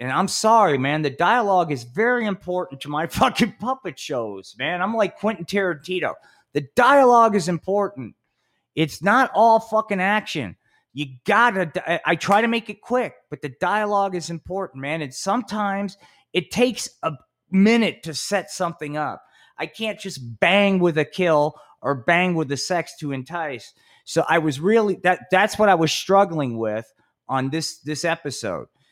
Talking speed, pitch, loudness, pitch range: 170 wpm, 180 Hz, -21 LUFS, 150-205 Hz